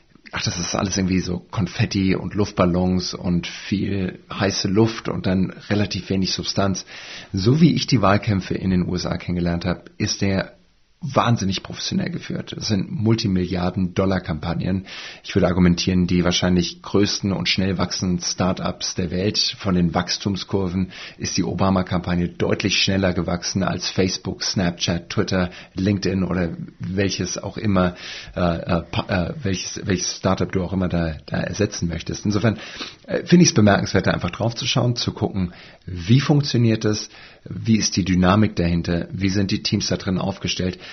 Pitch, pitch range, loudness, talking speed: 95 Hz, 90-105 Hz, -21 LUFS, 160 wpm